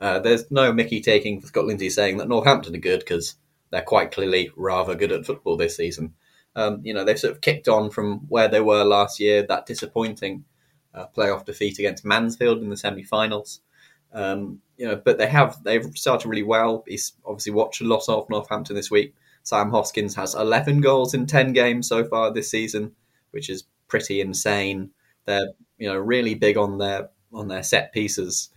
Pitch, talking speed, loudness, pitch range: 110 Hz, 195 wpm, -22 LUFS, 100-120 Hz